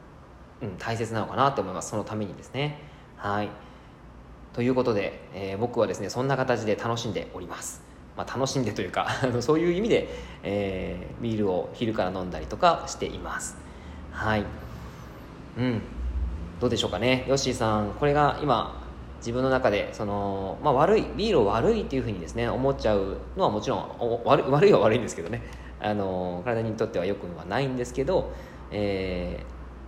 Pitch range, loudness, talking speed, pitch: 90-125 Hz, -27 LUFS, 360 characters per minute, 105 Hz